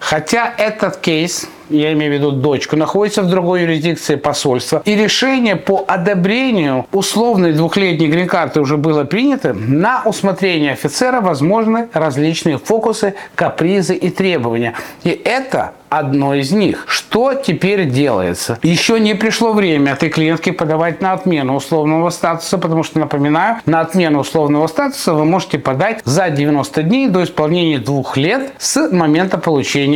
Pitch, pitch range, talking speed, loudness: 165 Hz, 150-195 Hz, 140 wpm, -14 LUFS